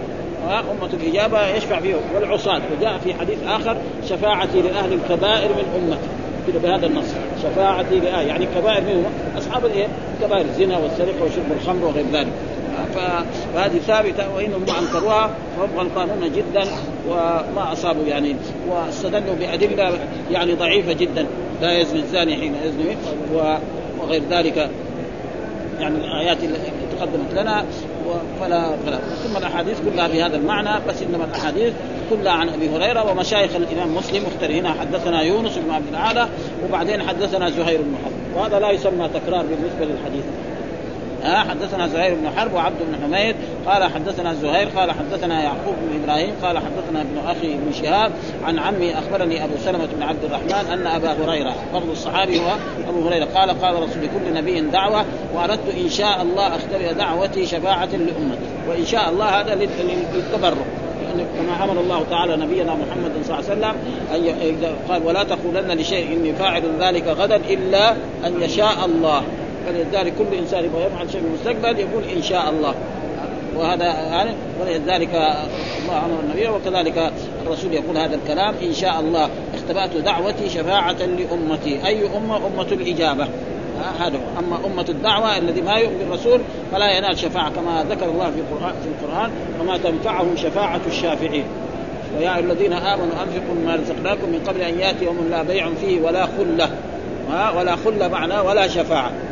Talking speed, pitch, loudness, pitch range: 150 wpm, 175 Hz, -20 LUFS, 165-195 Hz